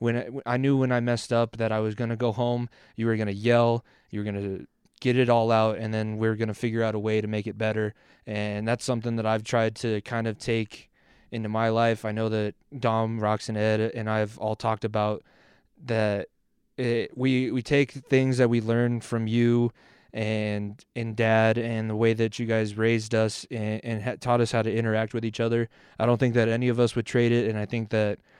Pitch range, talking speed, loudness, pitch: 110-120 Hz, 245 wpm, -26 LUFS, 115 Hz